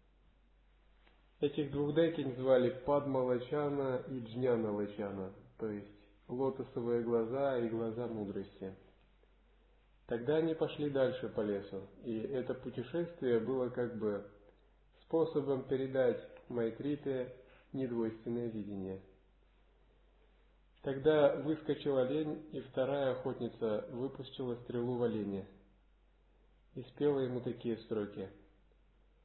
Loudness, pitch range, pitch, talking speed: -37 LUFS, 110-135 Hz, 125 Hz, 95 wpm